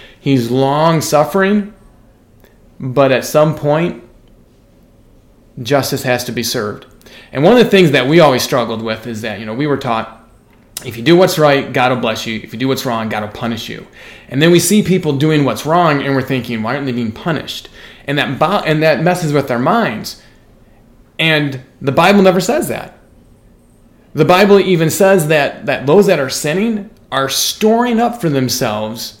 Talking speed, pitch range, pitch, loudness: 190 wpm, 120-165 Hz, 140 Hz, -13 LUFS